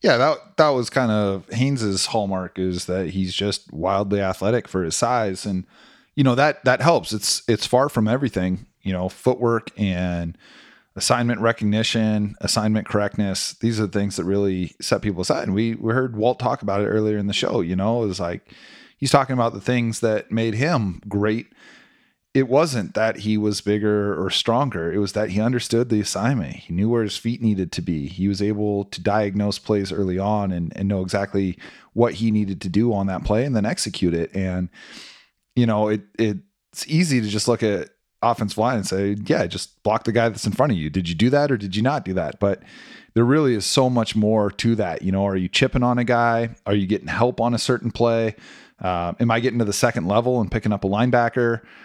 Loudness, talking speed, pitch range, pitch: -21 LUFS, 220 wpm, 100-120 Hz, 105 Hz